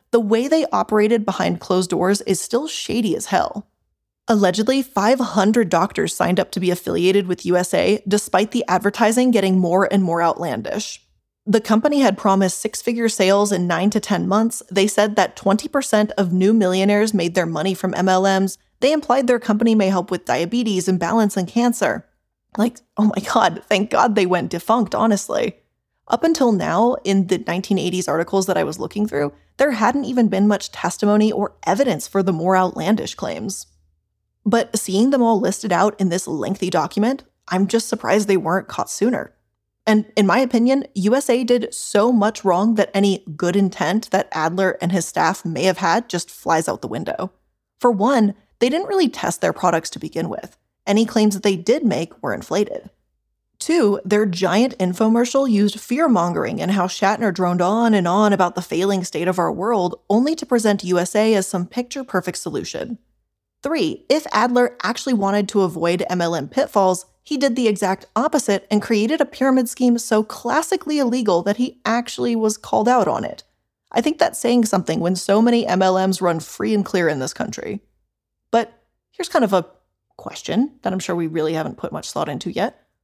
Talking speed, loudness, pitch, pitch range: 185 wpm, -19 LUFS, 205 Hz, 185-235 Hz